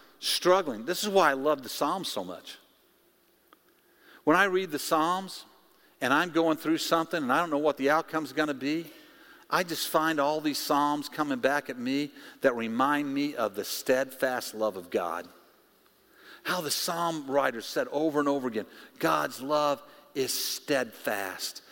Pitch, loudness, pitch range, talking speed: 150 Hz, -28 LUFS, 140-165 Hz, 175 wpm